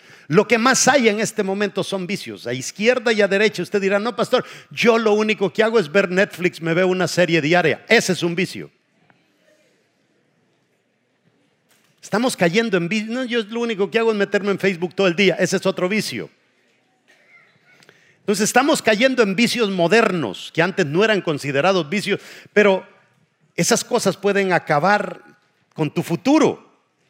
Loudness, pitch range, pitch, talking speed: -18 LUFS, 175-220 Hz, 200 Hz, 170 wpm